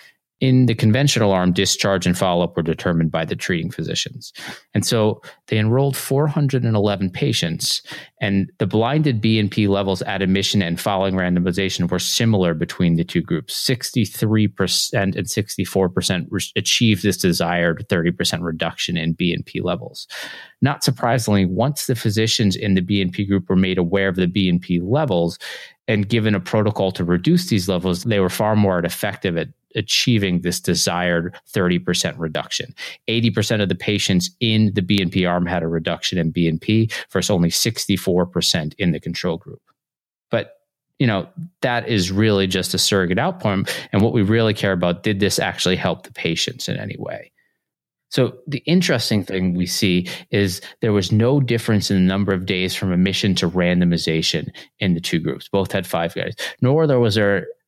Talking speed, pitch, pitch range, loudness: 170 wpm, 100 Hz, 90-115 Hz, -19 LUFS